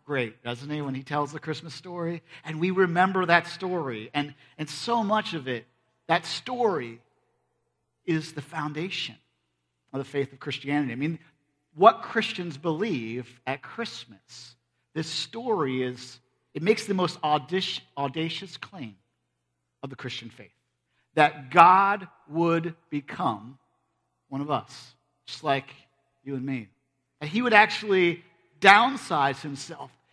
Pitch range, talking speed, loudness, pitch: 130-170 Hz, 135 wpm, -26 LUFS, 150 Hz